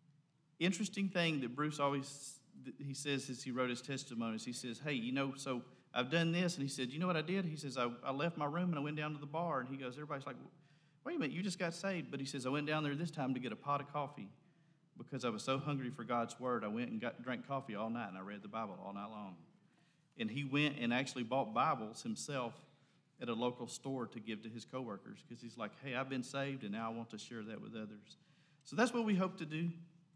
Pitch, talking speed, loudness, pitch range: 140 Hz, 265 wpm, -40 LUFS, 125-160 Hz